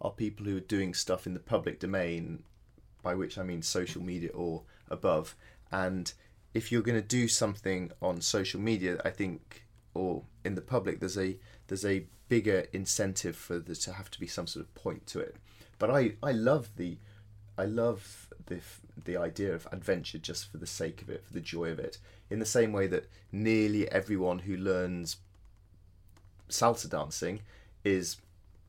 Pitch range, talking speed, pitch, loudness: 90-105 Hz, 180 wpm, 95 Hz, -33 LUFS